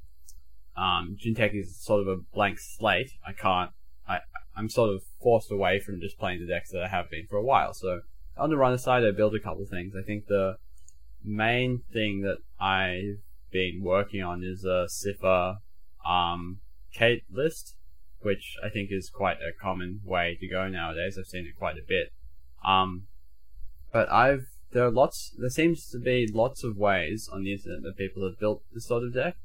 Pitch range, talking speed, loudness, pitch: 85-105 Hz, 195 wpm, -28 LUFS, 95 Hz